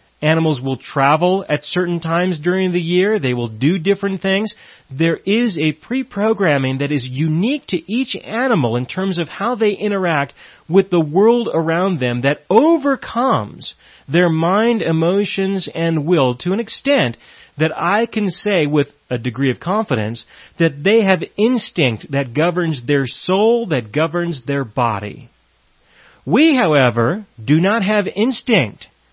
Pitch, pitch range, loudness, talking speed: 170 Hz, 140-205 Hz, -17 LUFS, 150 wpm